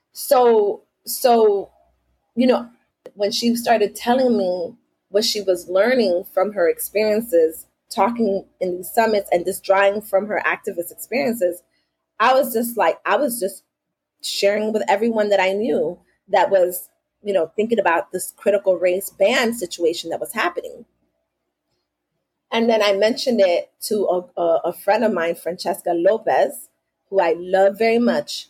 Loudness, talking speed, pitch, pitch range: -19 LUFS, 150 wpm, 200 Hz, 175-230 Hz